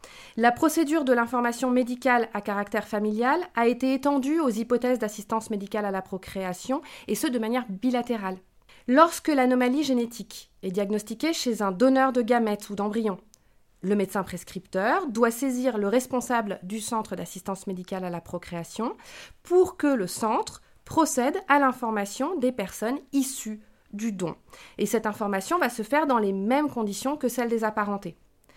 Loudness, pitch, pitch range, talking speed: -26 LUFS, 235 Hz, 205-260 Hz, 160 wpm